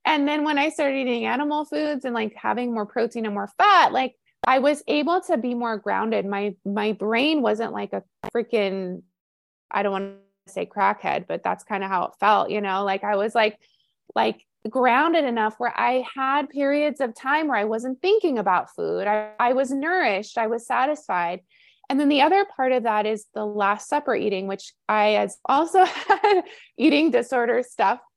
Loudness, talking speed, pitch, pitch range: -23 LUFS, 195 wpm, 235 Hz, 210-285 Hz